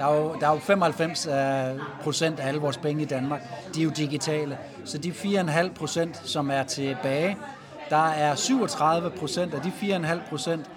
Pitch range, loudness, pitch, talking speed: 145-170 Hz, -26 LUFS, 155 Hz, 185 wpm